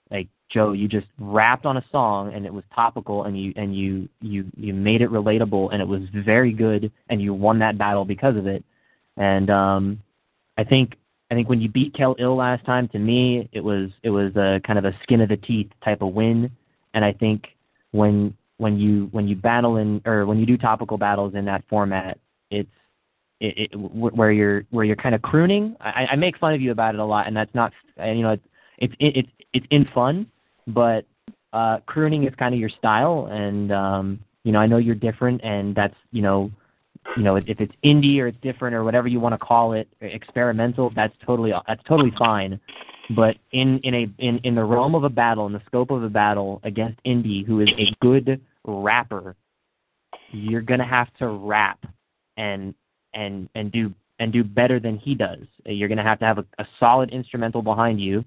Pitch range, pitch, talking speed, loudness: 105-120 Hz, 110 Hz, 215 wpm, -21 LUFS